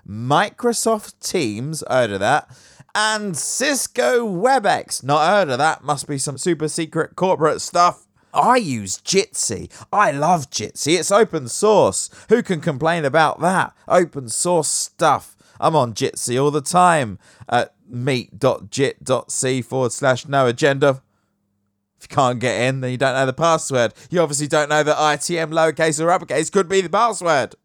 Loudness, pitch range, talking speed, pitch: -19 LUFS, 130-175 Hz, 155 wpm, 150 Hz